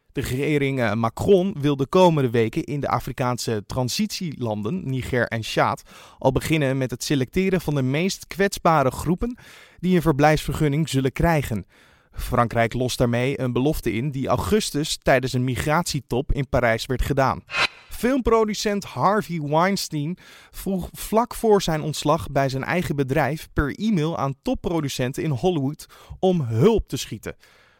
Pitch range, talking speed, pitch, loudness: 130-180 Hz, 140 wpm, 145 Hz, -22 LUFS